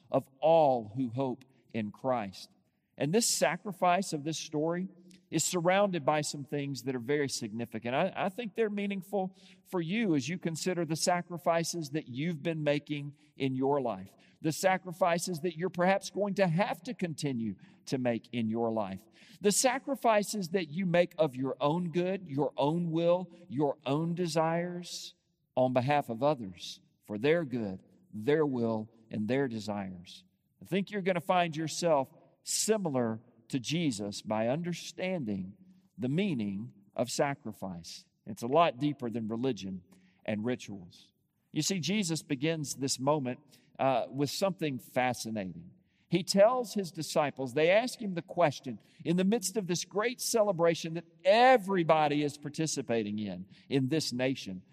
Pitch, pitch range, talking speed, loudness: 155 Hz, 125-180 Hz, 155 wpm, -31 LUFS